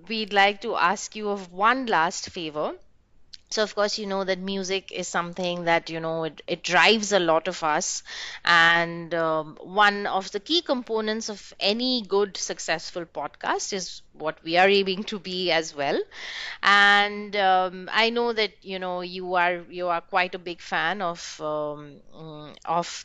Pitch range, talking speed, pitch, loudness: 170-205 Hz, 175 wpm, 185 Hz, -24 LUFS